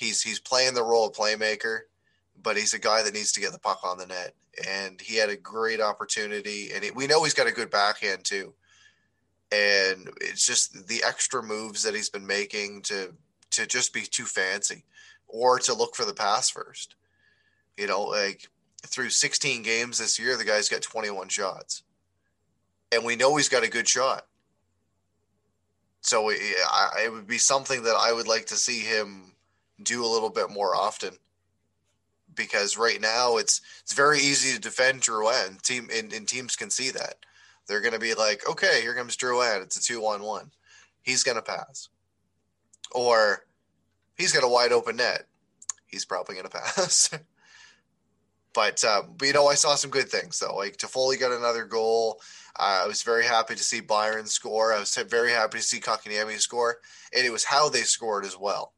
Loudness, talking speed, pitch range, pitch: -25 LUFS, 190 wpm, 100-125 Hz, 110 Hz